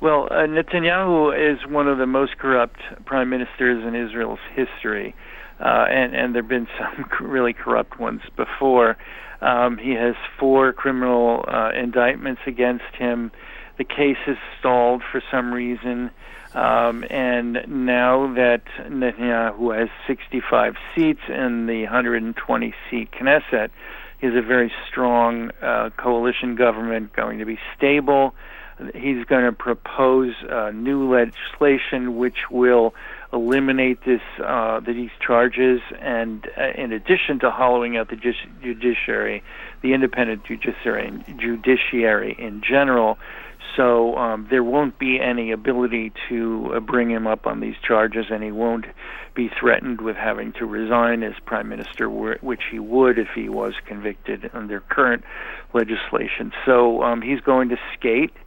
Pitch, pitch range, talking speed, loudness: 125 Hz, 115-130 Hz, 145 wpm, -21 LUFS